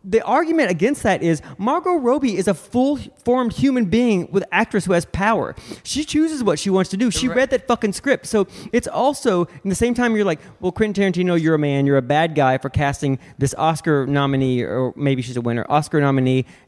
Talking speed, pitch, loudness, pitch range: 215 wpm, 190 Hz, -19 LUFS, 145-240 Hz